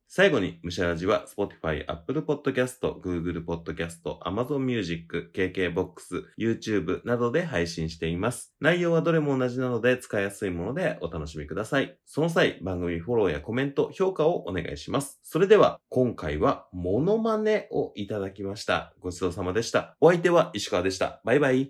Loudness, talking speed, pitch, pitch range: -27 LUFS, 455 characters per minute, 100 Hz, 85-130 Hz